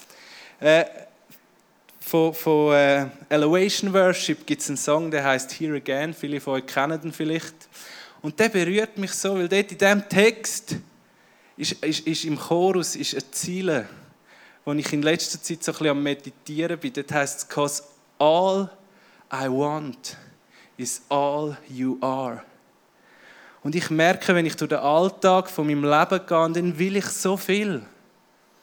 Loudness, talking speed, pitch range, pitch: -23 LUFS, 155 wpm, 145-185 Hz, 155 Hz